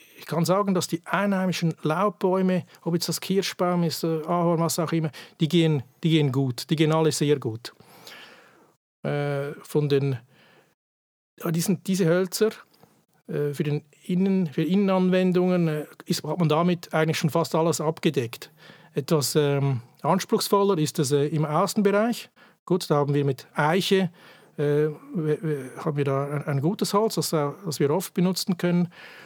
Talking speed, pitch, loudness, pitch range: 135 wpm, 165 Hz, -25 LUFS, 150-185 Hz